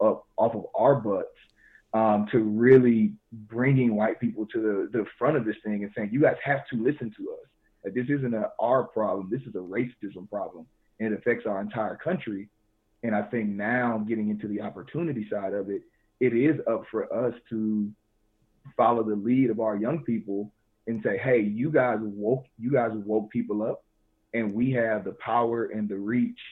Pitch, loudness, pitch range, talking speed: 110 Hz, -27 LUFS, 105-120 Hz, 195 wpm